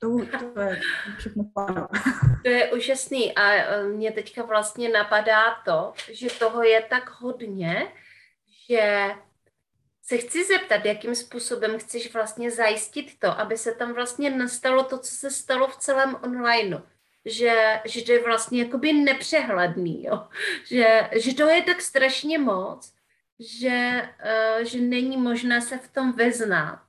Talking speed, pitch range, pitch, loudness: 135 wpm, 220-255 Hz, 235 Hz, -23 LUFS